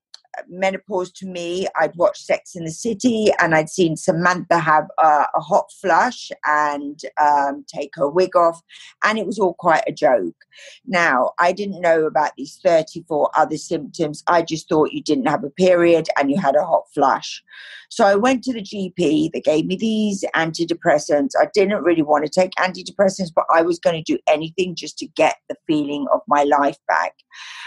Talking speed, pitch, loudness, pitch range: 190 wpm, 175 Hz, -19 LUFS, 155-200 Hz